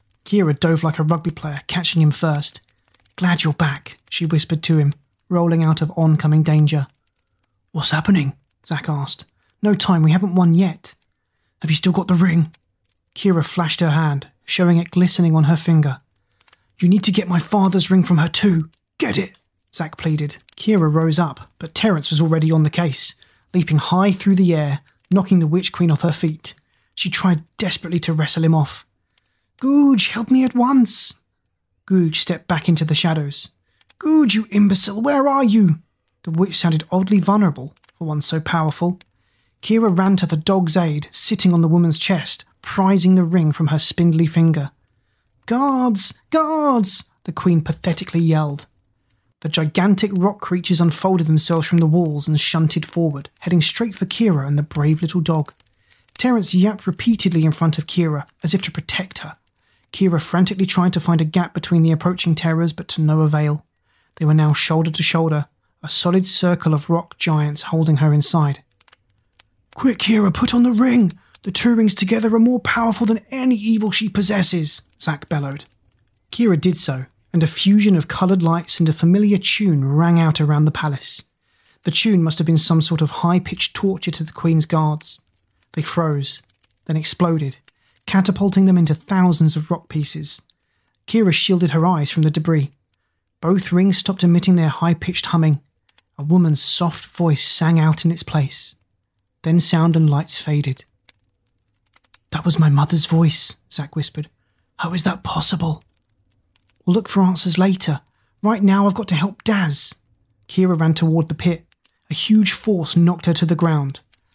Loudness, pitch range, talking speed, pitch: -18 LUFS, 150-185 Hz, 175 wpm, 165 Hz